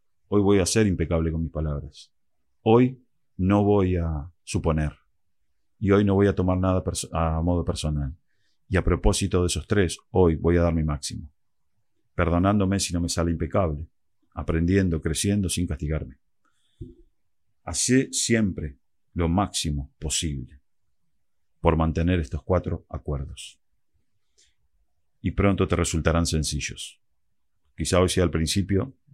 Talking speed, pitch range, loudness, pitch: 135 wpm, 80-95 Hz, -24 LUFS, 85 Hz